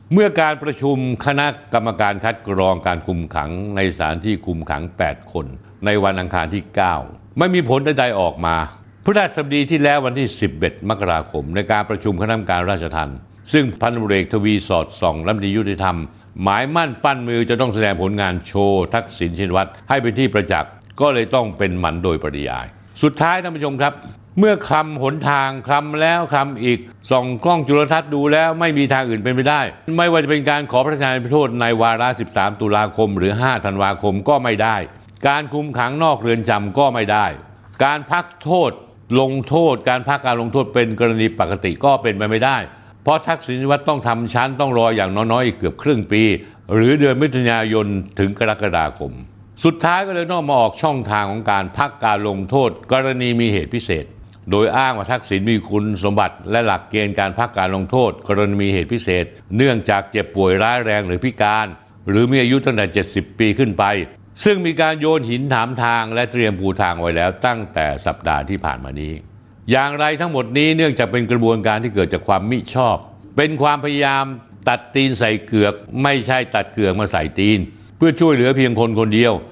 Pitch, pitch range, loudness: 115 Hz, 100-135 Hz, -18 LUFS